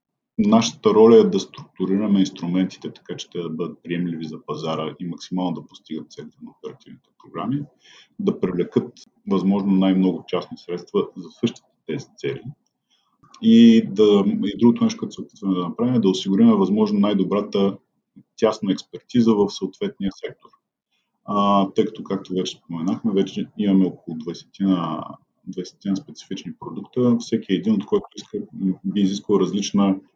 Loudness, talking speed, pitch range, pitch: -21 LUFS, 145 wpm, 95-145 Hz, 100 Hz